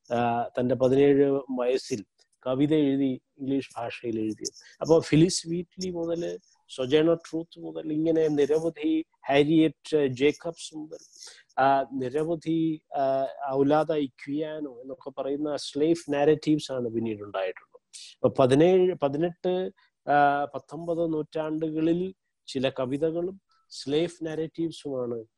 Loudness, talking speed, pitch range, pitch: -27 LUFS, 85 wpm, 135-165 Hz, 150 Hz